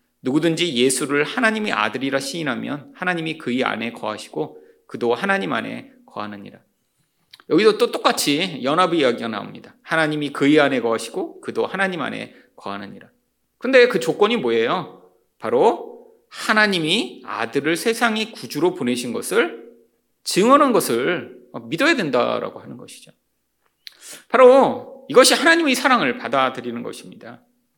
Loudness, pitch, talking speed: -19 LUFS, 215 Hz, 330 characters per minute